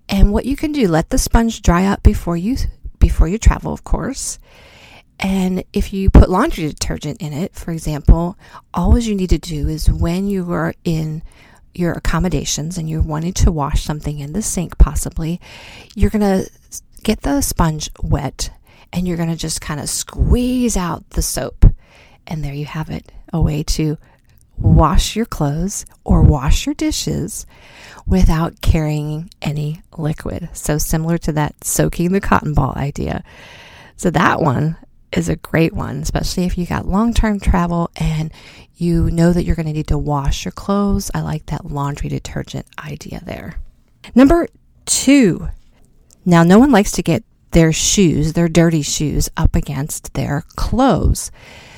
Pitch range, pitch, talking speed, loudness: 150-195 Hz, 165 Hz, 165 wpm, -17 LUFS